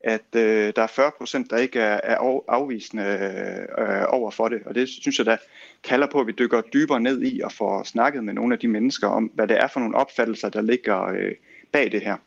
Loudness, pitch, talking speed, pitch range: -23 LUFS, 120 Hz, 235 wpm, 110-145 Hz